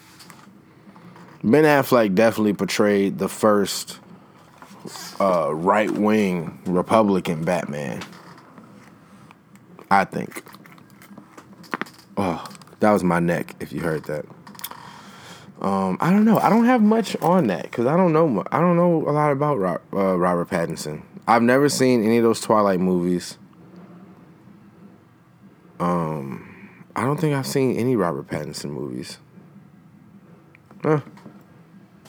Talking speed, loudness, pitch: 120 wpm, -21 LUFS, 135 Hz